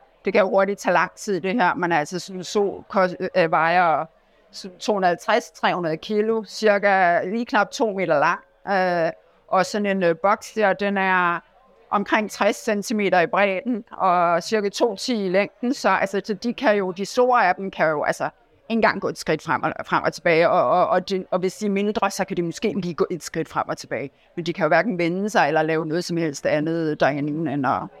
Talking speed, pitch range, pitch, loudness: 225 wpm, 175-210 Hz, 195 Hz, -22 LUFS